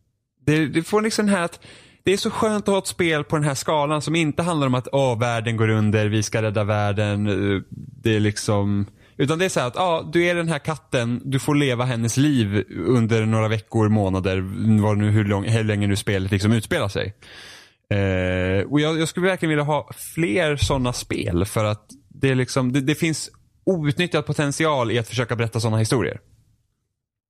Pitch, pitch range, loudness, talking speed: 120 Hz, 105-150 Hz, -21 LUFS, 205 wpm